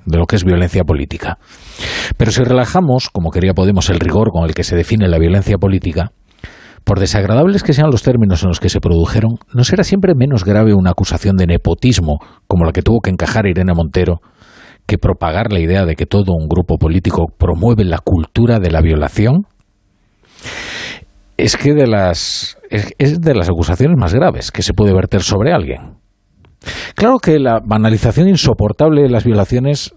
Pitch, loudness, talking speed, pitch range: 100 Hz, -13 LUFS, 180 wpm, 90-115 Hz